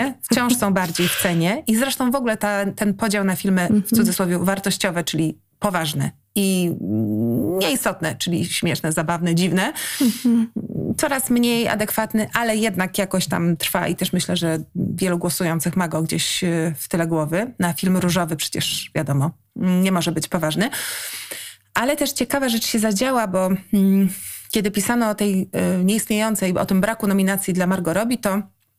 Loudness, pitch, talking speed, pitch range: -20 LUFS, 190 Hz, 155 wpm, 175-220 Hz